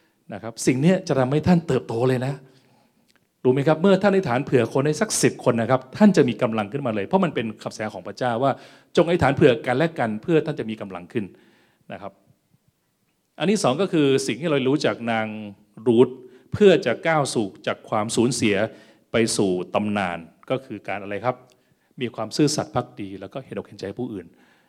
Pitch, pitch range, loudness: 125 Hz, 110-140 Hz, -22 LUFS